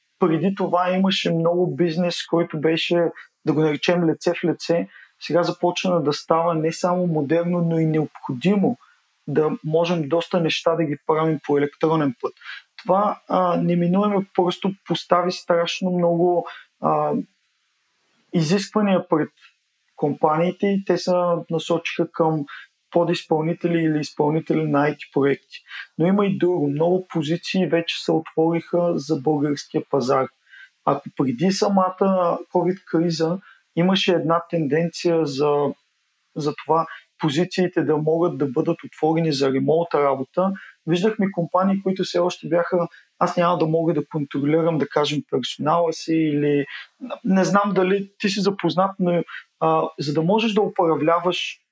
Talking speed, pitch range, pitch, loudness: 135 wpm, 160-180 Hz, 170 Hz, -21 LUFS